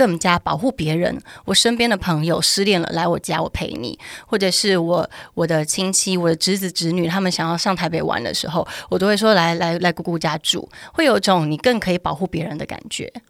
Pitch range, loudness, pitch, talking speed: 170-195 Hz, -19 LUFS, 175 Hz, 325 characters per minute